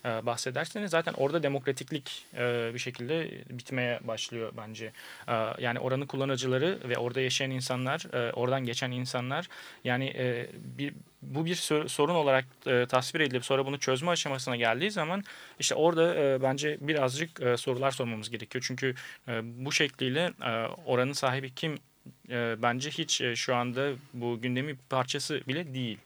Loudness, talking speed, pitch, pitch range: -31 LUFS, 125 wpm, 130 Hz, 125-145 Hz